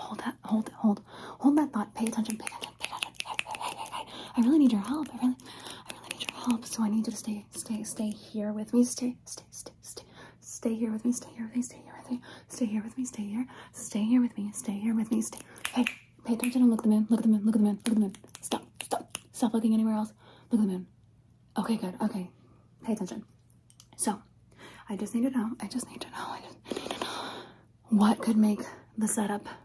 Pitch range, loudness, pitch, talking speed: 215-245 Hz, -30 LUFS, 225 Hz, 265 wpm